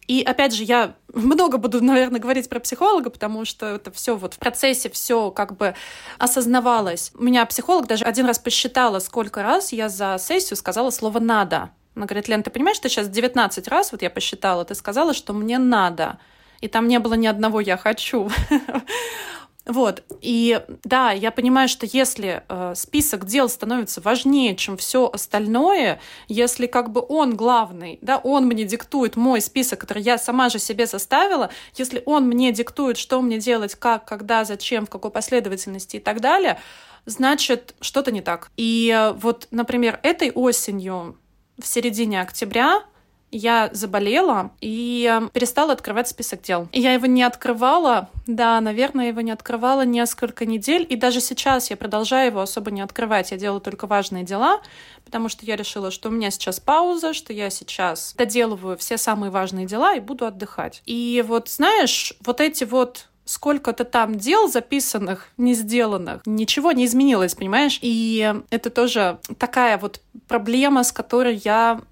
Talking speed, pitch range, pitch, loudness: 165 wpm, 215-255 Hz, 235 Hz, -20 LUFS